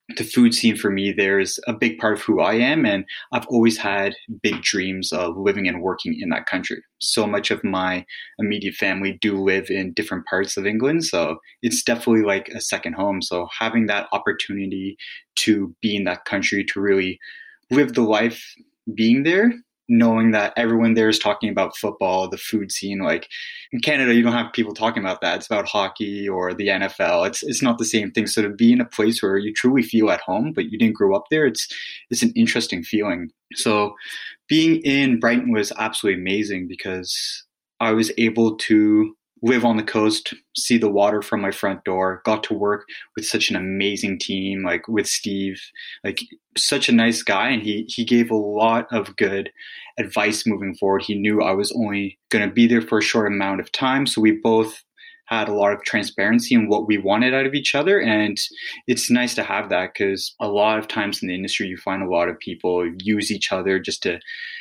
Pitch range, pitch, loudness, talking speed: 100-120 Hz, 110 Hz, -20 LUFS, 210 wpm